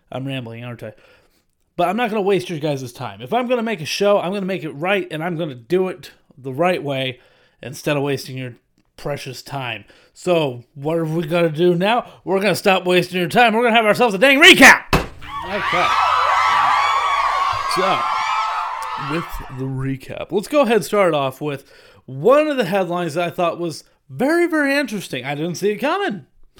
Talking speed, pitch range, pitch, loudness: 210 wpm, 135-205 Hz, 175 Hz, -17 LUFS